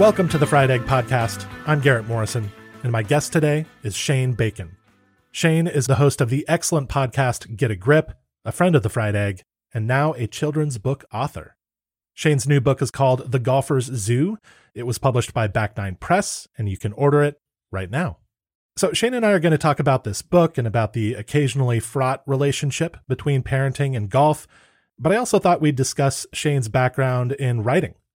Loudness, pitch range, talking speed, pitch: -21 LUFS, 115-150 Hz, 195 wpm, 135 Hz